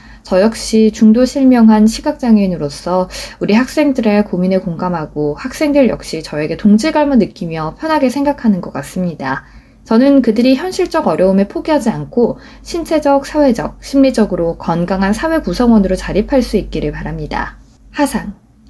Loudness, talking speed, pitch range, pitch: -14 LUFS, 345 characters per minute, 180-270 Hz, 215 Hz